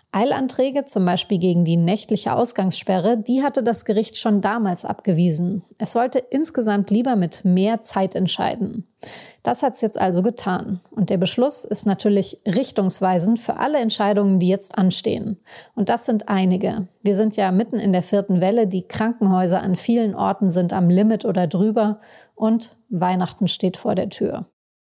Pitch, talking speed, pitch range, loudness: 205 Hz, 165 wpm, 185-230 Hz, -19 LUFS